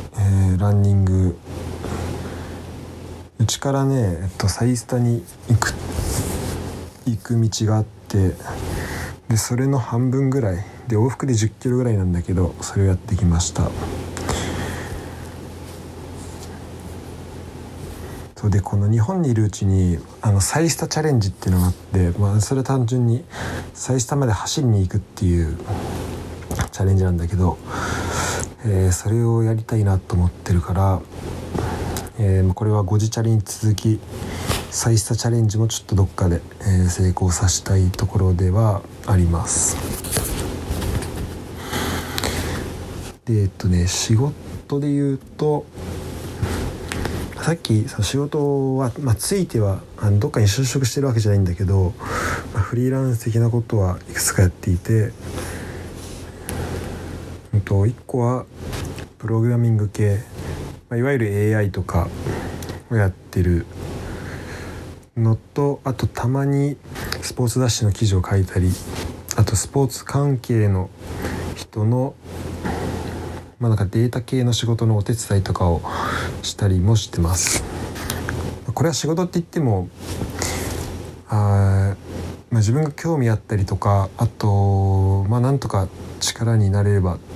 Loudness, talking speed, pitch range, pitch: -21 LUFS, 260 characters per minute, 90-115 Hz, 100 Hz